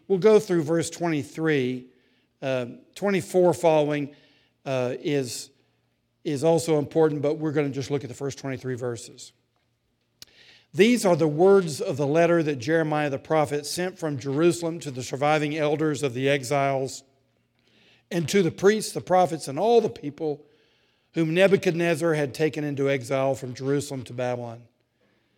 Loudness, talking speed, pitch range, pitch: -24 LUFS, 155 wpm, 135-165 Hz, 145 Hz